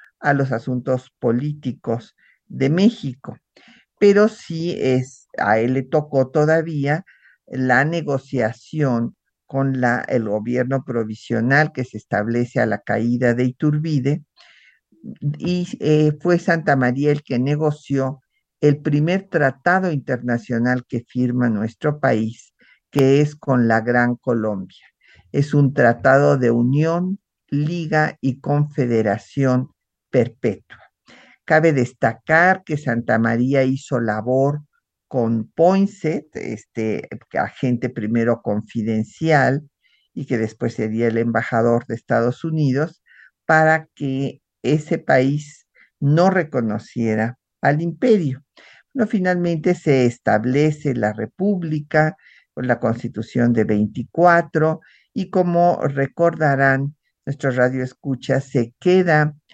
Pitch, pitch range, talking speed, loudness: 135 Hz, 120-155 Hz, 110 wpm, -19 LUFS